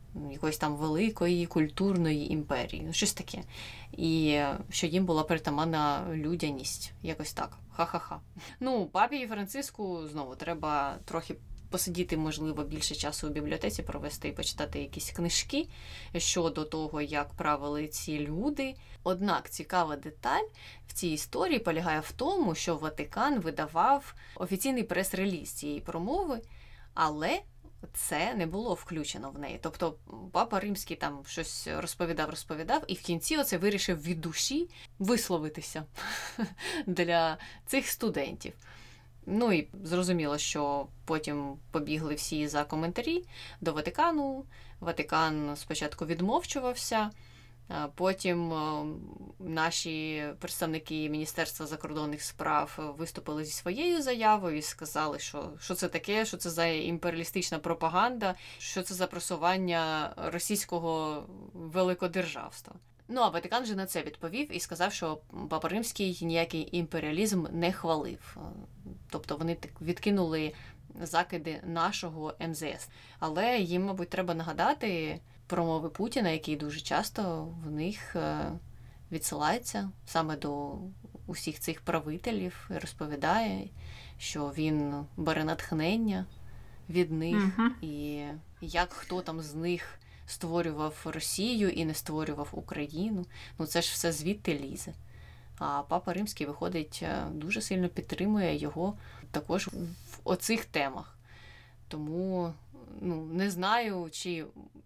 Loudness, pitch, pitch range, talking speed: -33 LUFS, 165 Hz, 155-185 Hz, 120 wpm